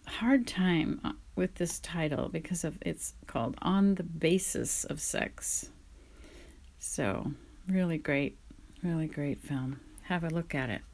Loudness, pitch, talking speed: -32 LUFS, 160 Hz, 135 wpm